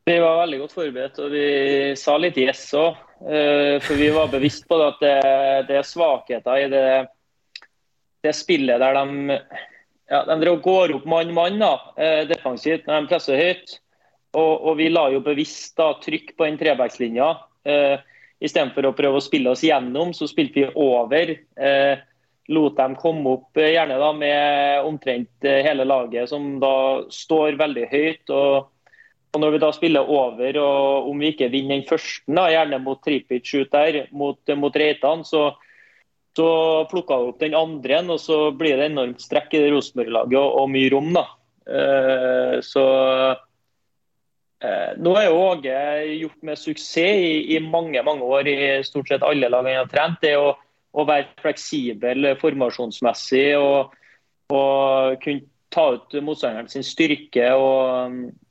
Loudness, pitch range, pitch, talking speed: -20 LUFS, 135-155 Hz, 145 Hz, 155 wpm